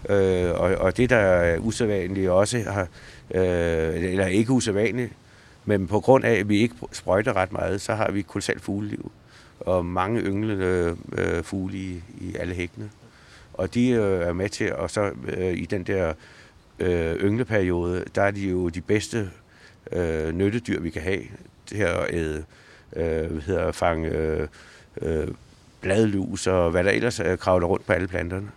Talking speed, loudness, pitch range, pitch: 170 wpm, -24 LUFS, 90-105 Hz, 95 Hz